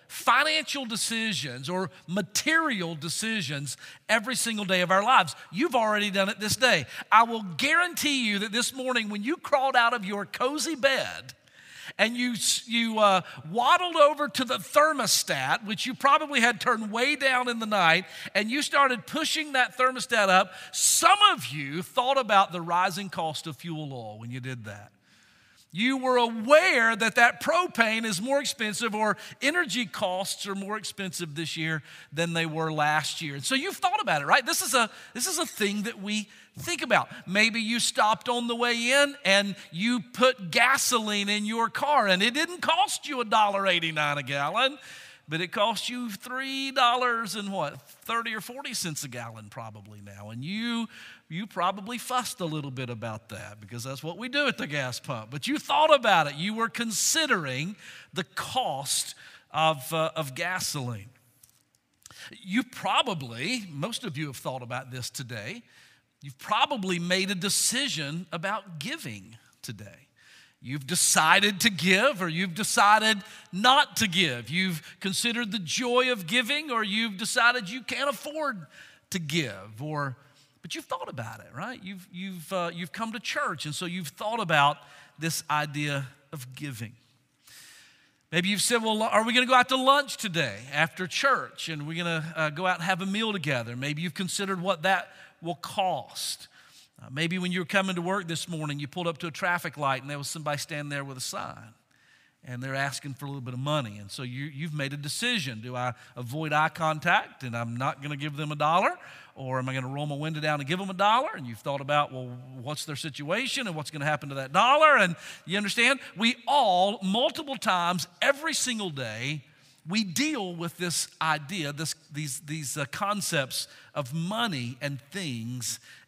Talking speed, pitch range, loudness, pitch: 185 wpm, 150-235 Hz, -26 LUFS, 190 Hz